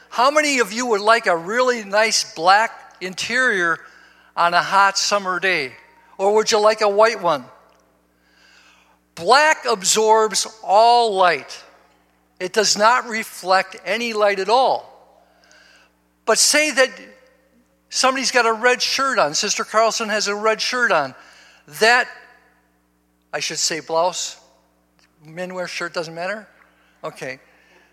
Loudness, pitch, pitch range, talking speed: -18 LUFS, 215 Hz, 175-240 Hz, 135 wpm